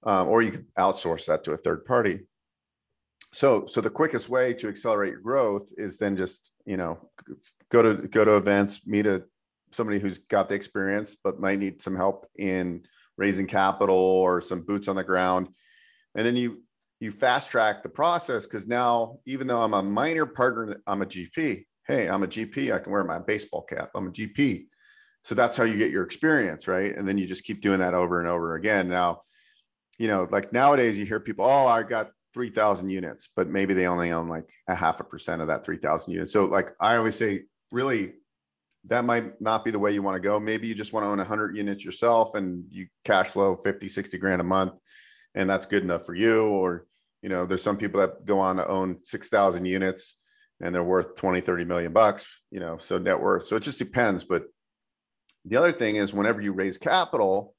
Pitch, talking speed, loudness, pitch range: 100 Hz, 215 wpm, -26 LUFS, 95-110 Hz